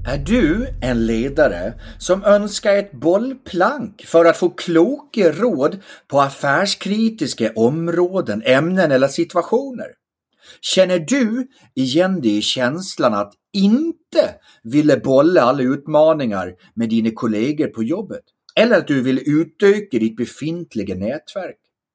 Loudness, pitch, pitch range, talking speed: -17 LUFS, 170 Hz, 130-205 Hz, 120 wpm